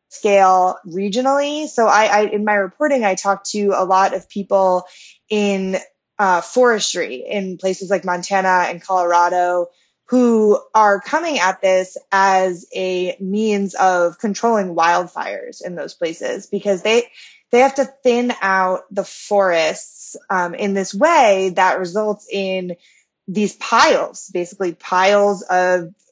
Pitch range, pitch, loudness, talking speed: 185-215 Hz, 195 Hz, -17 LUFS, 135 wpm